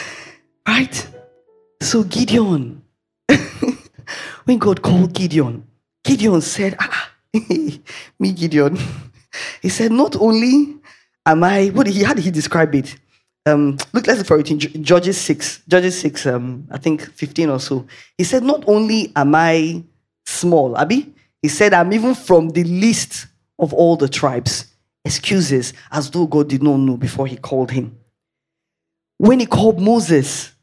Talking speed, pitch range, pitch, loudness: 155 wpm, 140-205 Hz, 165 Hz, -16 LUFS